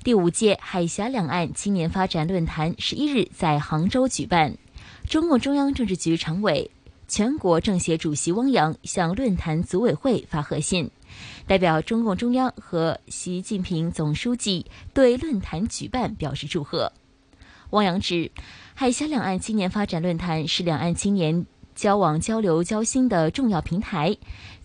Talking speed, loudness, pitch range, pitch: 240 characters per minute, -23 LUFS, 165-220 Hz, 185 Hz